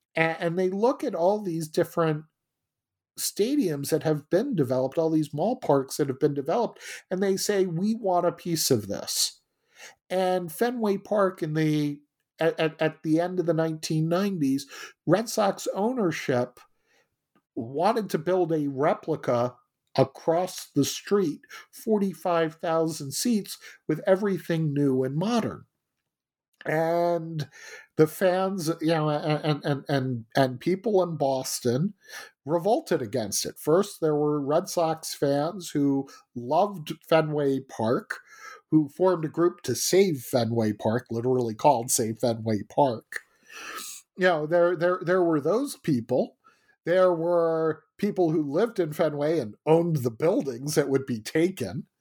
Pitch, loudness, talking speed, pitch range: 165 Hz, -26 LUFS, 140 wpm, 145-185 Hz